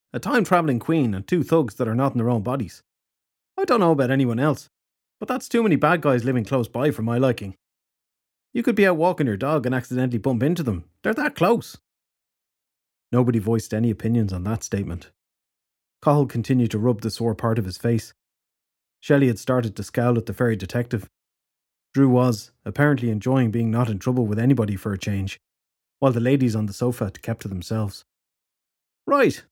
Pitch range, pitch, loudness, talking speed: 105-135 Hz, 120 Hz, -22 LUFS, 195 wpm